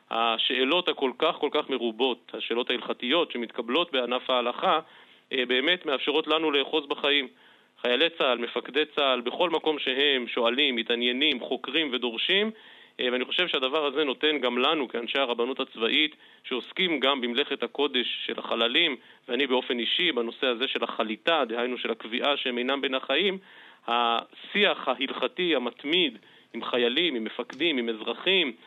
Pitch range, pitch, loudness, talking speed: 120-155 Hz, 135 Hz, -26 LUFS, 140 wpm